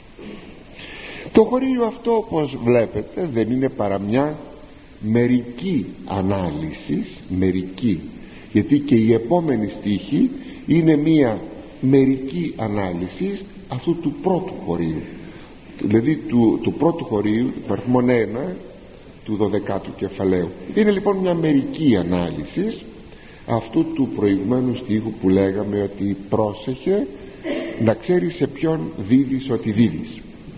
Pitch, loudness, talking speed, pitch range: 125 Hz, -20 LUFS, 110 wpm, 105-155 Hz